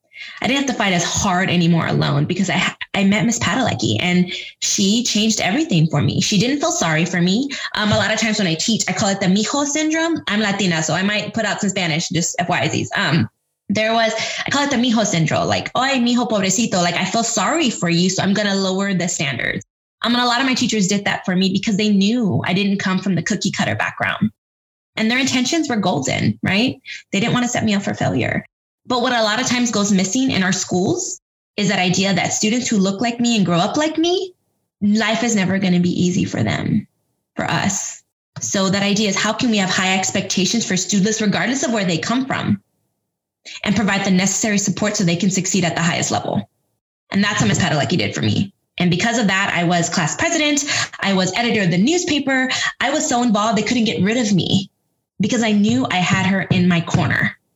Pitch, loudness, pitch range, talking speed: 200 Hz, -18 LUFS, 180-230 Hz, 230 wpm